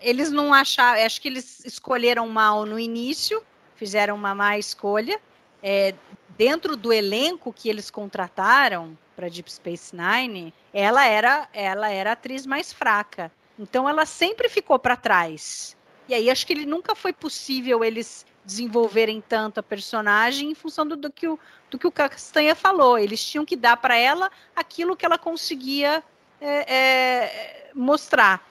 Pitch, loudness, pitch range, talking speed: 245 Hz, -21 LUFS, 210-300 Hz, 160 wpm